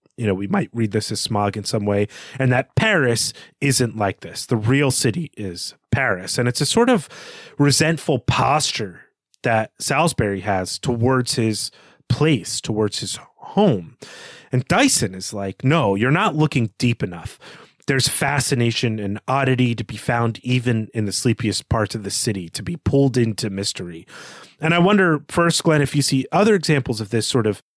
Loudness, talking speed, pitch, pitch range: -20 LUFS, 175 wpm, 125 Hz, 110-145 Hz